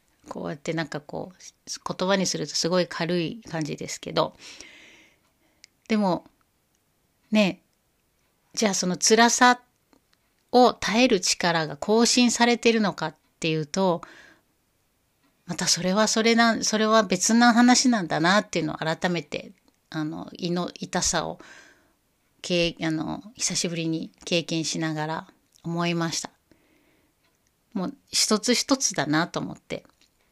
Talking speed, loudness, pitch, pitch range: 240 characters per minute, -23 LUFS, 180 Hz, 160-225 Hz